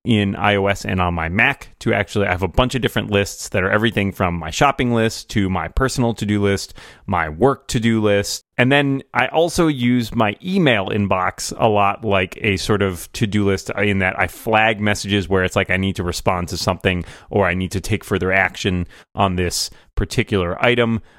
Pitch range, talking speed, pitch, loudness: 95-115 Hz, 205 wpm, 100 Hz, -19 LUFS